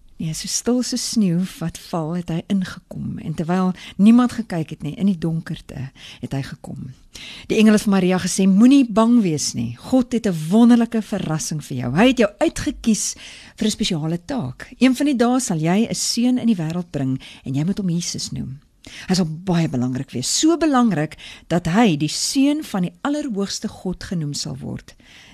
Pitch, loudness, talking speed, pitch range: 185 Hz, -19 LUFS, 205 wpm, 160-230 Hz